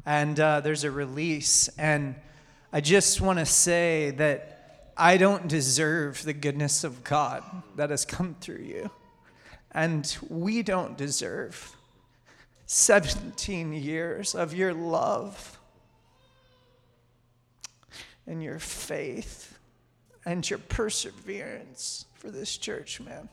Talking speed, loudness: 110 wpm, -26 LUFS